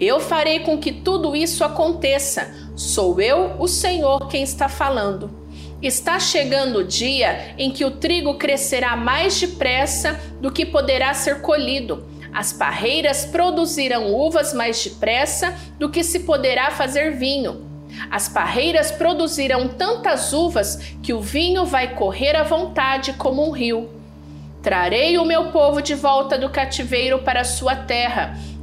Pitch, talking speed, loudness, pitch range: 280 Hz, 145 wpm, -19 LUFS, 255-315 Hz